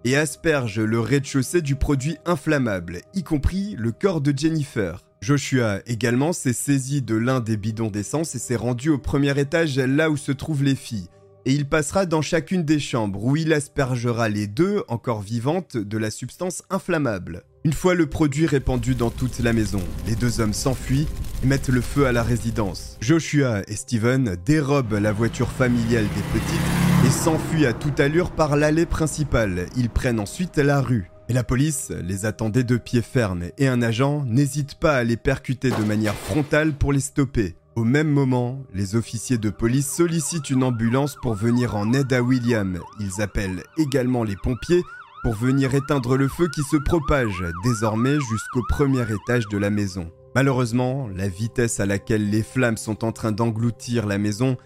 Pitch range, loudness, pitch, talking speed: 110-145 Hz, -22 LUFS, 125 Hz, 180 wpm